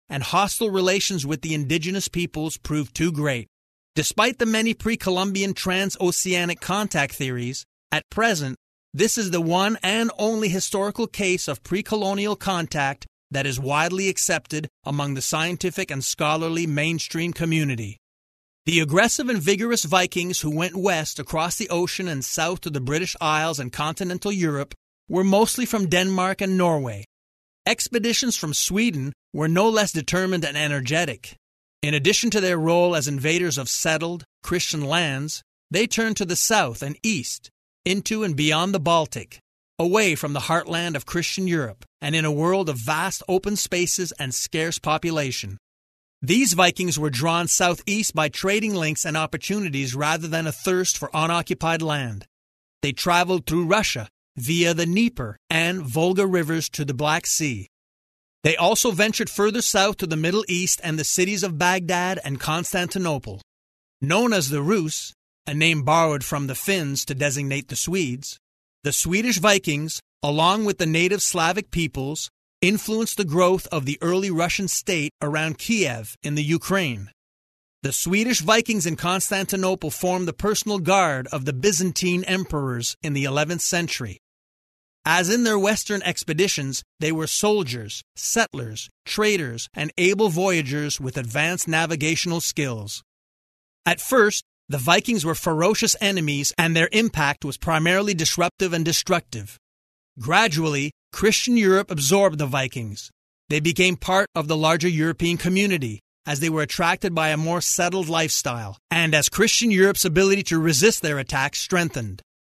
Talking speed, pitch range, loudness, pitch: 150 wpm, 145-190 Hz, -22 LUFS, 165 Hz